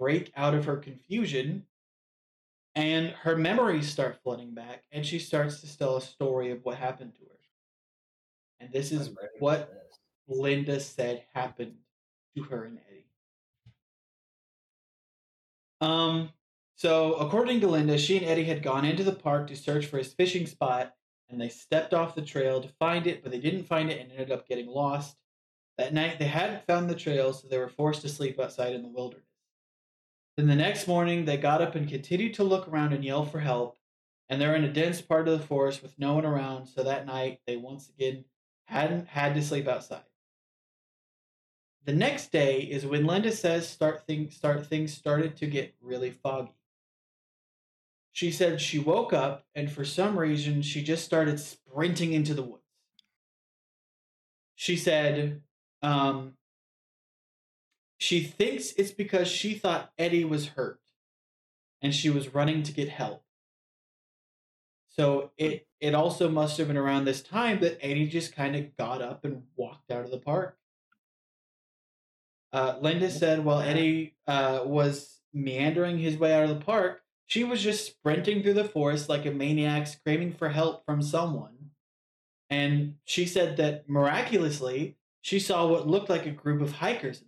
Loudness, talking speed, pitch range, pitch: -29 LUFS, 170 wpm, 135-160 Hz, 150 Hz